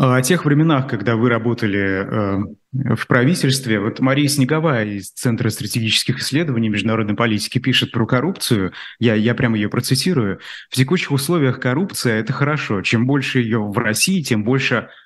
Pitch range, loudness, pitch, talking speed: 110-135 Hz, -18 LUFS, 120 Hz, 155 wpm